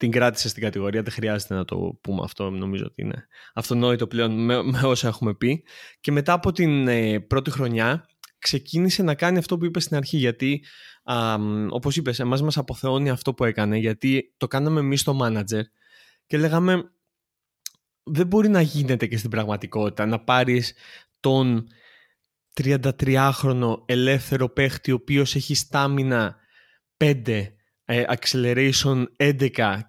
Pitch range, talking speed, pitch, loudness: 115-140 Hz, 145 wpm, 130 Hz, -23 LUFS